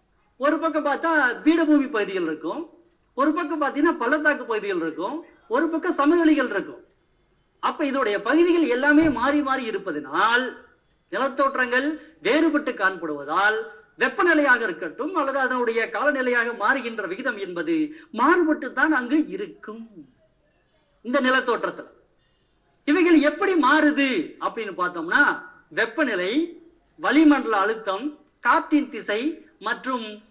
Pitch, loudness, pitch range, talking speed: 285 Hz, -22 LUFS, 230-315 Hz, 100 wpm